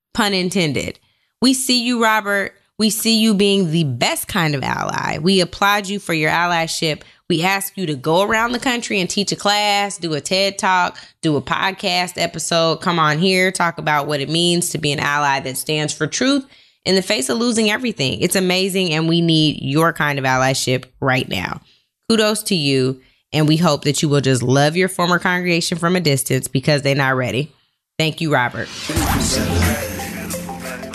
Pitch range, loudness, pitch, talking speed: 145-195 Hz, -17 LUFS, 170 Hz, 190 wpm